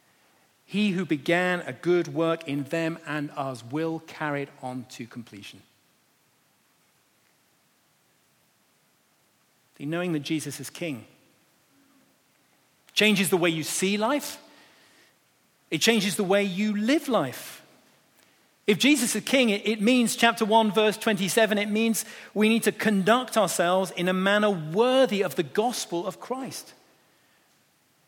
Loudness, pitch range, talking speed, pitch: -25 LUFS, 160-220 Hz, 130 wpm, 195 Hz